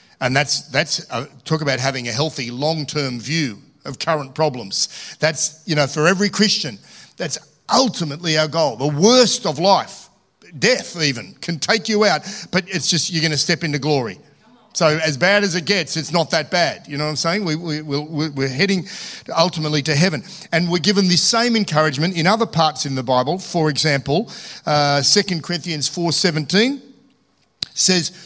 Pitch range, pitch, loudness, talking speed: 150-190 Hz, 165 Hz, -18 LUFS, 180 wpm